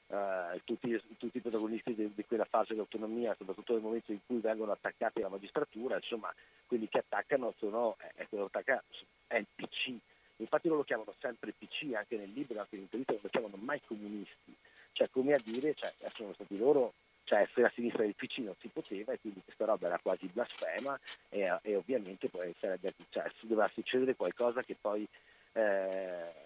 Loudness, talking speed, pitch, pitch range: -37 LUFS, 190 wpm, 115 Hz, 105-125 Hz